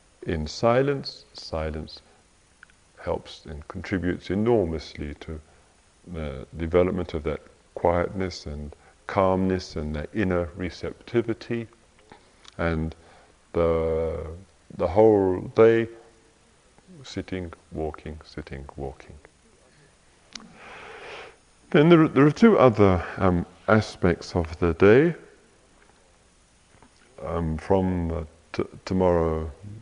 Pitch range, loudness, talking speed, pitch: 80-105 Hz, -24 LUFS, 90 wpm, 90 Hz